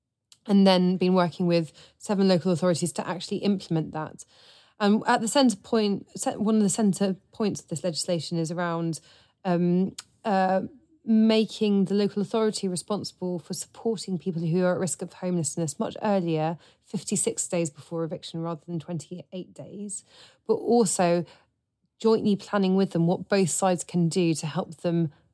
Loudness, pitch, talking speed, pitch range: -26 LUFS, 185 Hz, 160 wpm, 170-205 Hz